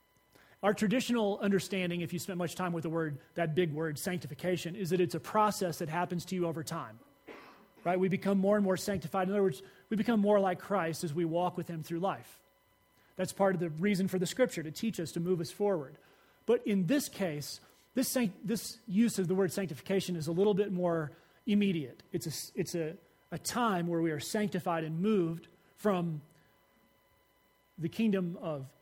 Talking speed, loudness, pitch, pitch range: 200 wpm, -33 LUFS, 180 Hz, 165-200 Hz